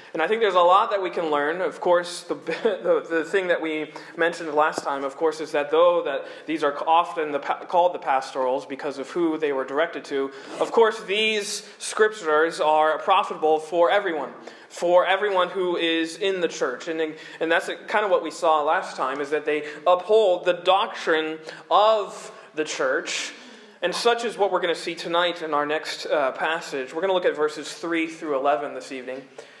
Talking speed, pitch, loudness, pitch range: 205 wpm, 170 Hz, -23 LUFS, 155-200 Hz